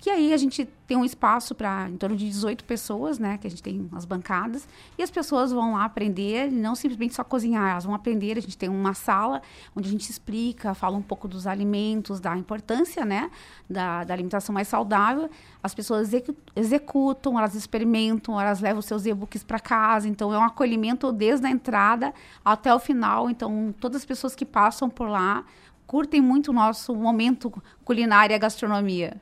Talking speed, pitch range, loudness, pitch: 195 wpm, 205-250 Hz, -25 LUFS, 220 Hz